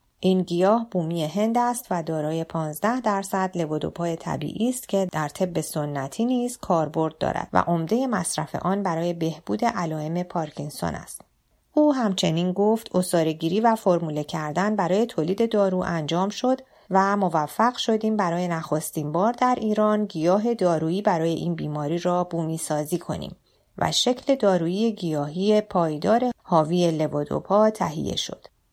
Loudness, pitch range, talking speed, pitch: -24 LUFS, 165-215 Hz, 140 wpm, 180 Hz